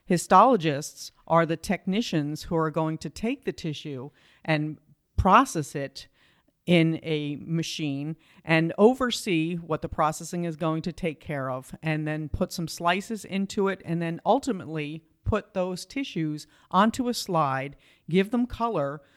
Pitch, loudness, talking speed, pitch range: 165 Hz, -26 LUFS, 145 wpm, 155-185 Hz